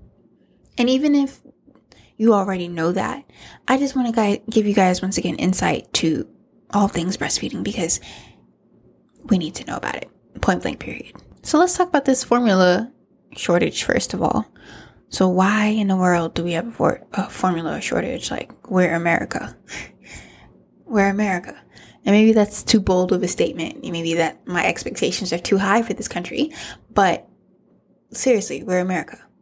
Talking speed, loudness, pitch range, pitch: 165 wpm, -20 LUFS, 180-235 Hz, 200 Hz